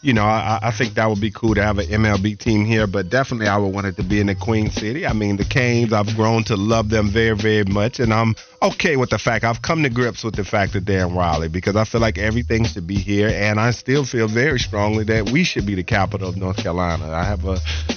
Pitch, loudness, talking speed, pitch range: 110 Hz, -19 LUFS, 275 wpm, 100-115 Hz